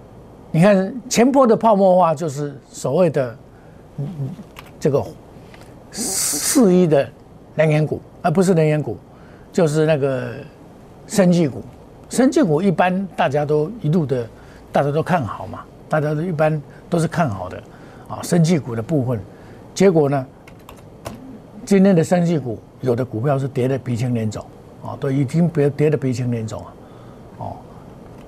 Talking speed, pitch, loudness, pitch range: 215 characters per minute, 150 Hz, -18 LUFS, 125-175 Hz